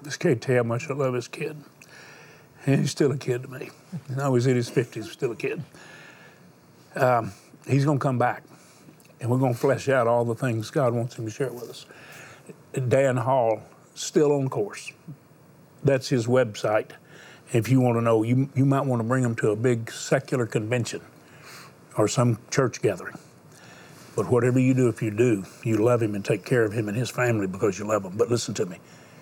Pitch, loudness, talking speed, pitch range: 130 Hz, -25 LUFS, 210 wpm, 120-135 Hz